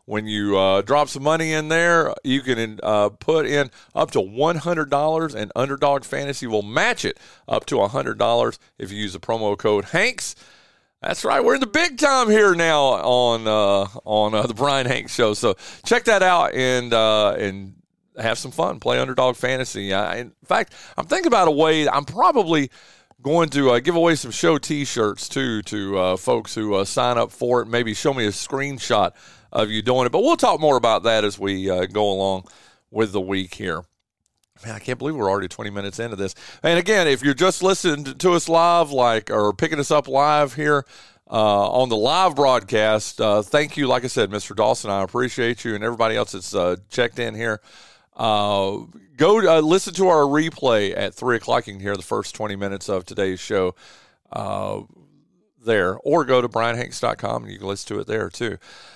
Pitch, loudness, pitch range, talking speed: 120 Hz, -20 LUFS, 105-145 Hz, 200 wpm